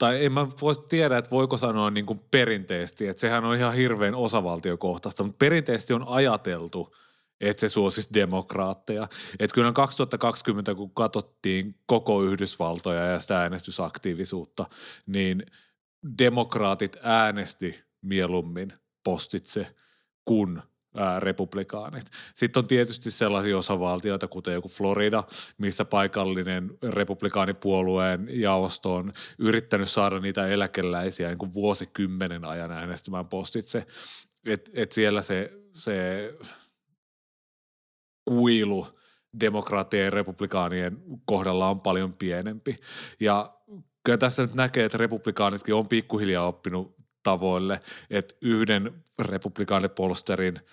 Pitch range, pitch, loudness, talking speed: 95-115 Hz, 100 Hz, -26 LUFS, 110 wpm